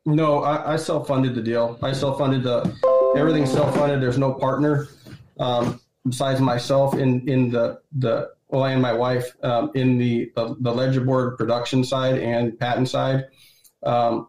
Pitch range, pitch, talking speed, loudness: 120-140 Hz, 130 Hz, 165 wpm, -22 LUFS